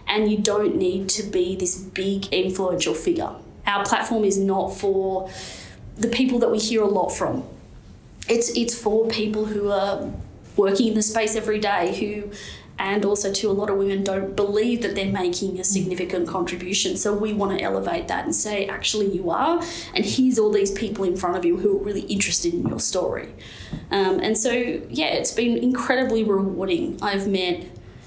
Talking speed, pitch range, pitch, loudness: 190 wpm, 190-220 Hz, 200 Hz, -22 LUFS